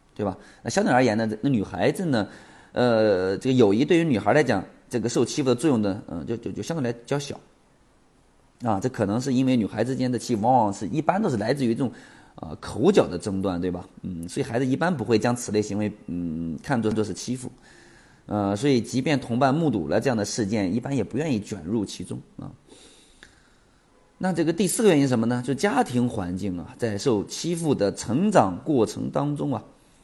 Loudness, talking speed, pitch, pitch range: -24 LUFS, 310 characters per minute, 120 Hz, 100-135 Hz